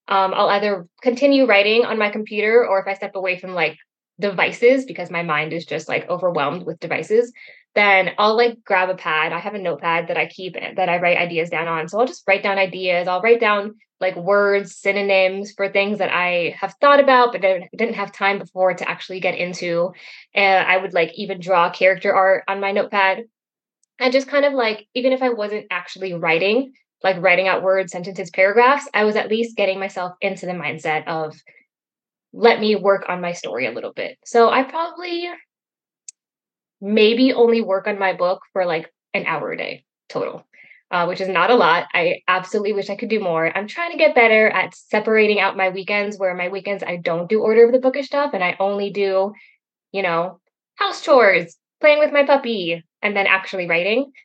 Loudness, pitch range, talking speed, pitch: -18 LUFS, 185-230 Hz, 205 wpm, 195 Hz